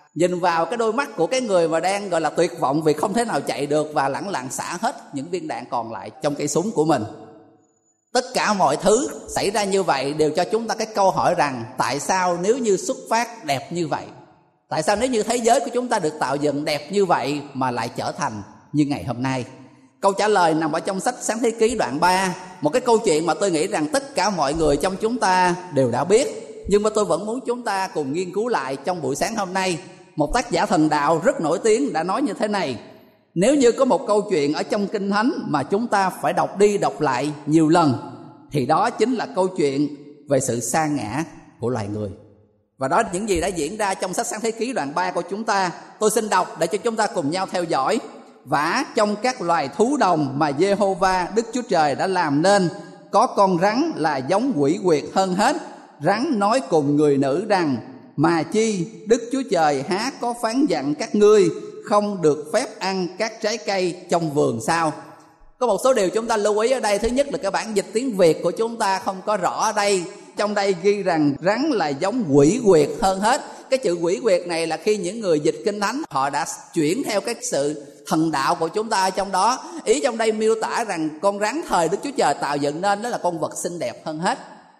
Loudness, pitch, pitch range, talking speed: -21 LUFS, 190 Hz, 150-220 Hz, 240 wpm